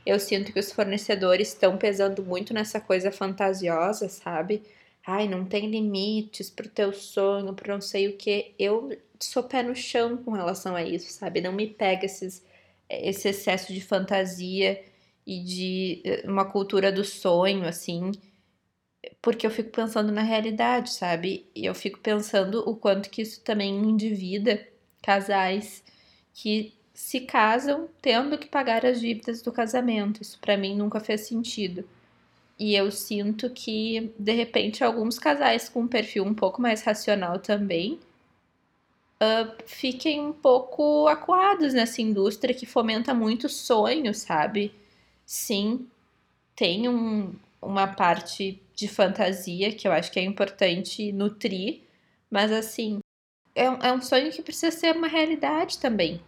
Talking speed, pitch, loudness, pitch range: 145 wpm, 210 Hz, -26 LUFS, 195-235 Hz